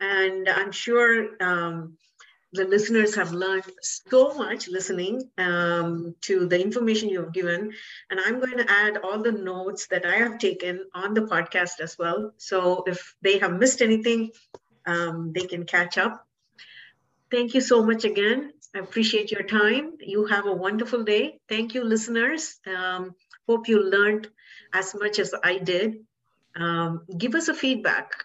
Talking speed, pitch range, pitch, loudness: 165 wpm, 185-230 Hz, 200 Hz, -24 LUFS